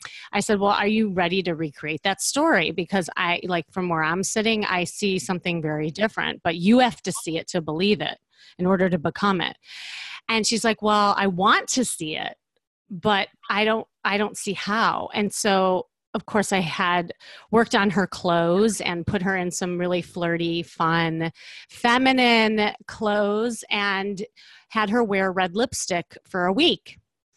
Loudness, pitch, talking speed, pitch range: -23 LUFS, 195 Hz, 180 wpm, 175-215 Hz